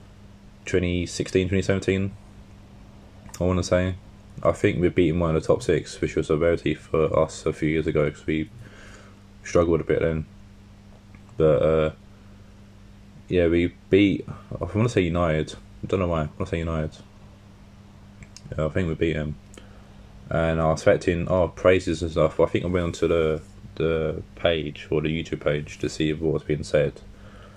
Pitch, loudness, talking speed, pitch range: 95 Hz, -24 LUFS, 180 wpm, 80-100 Hz